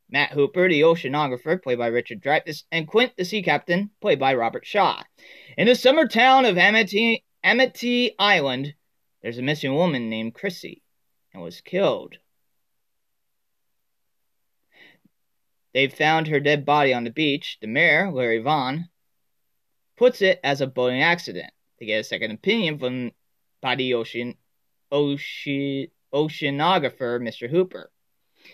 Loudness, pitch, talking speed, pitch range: -21 LUFS, 150 Hz, 135 wpm, 130-190 Hz